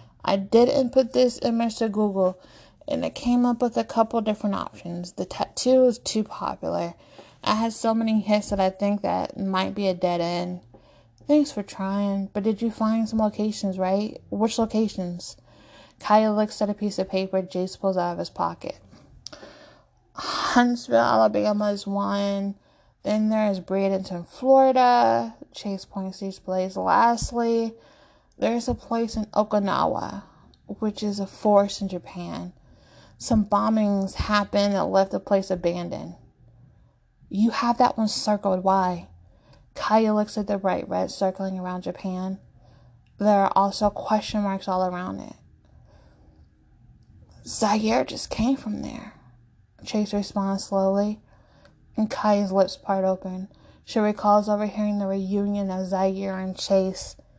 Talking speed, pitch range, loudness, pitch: 145 wpm, 185-215 Hz, -24 LUFS, 200 Hz